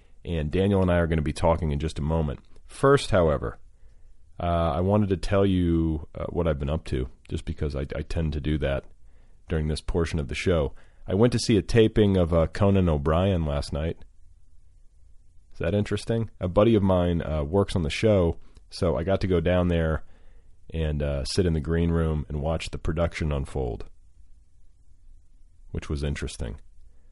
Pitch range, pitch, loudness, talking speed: 75-90 Hz, 85 Hz, -25 LUFS, 195 wpm